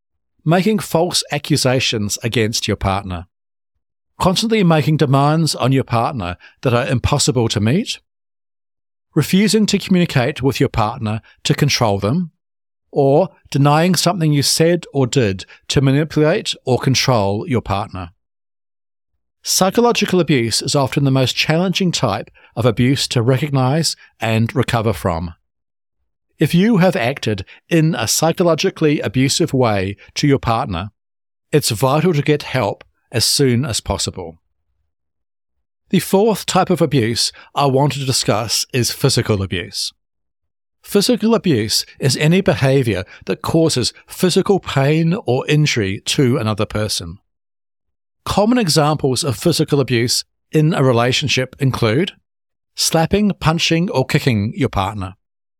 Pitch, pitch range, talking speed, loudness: 135 Hz, 105-155 Hz, 125 wpm, -16 LUFS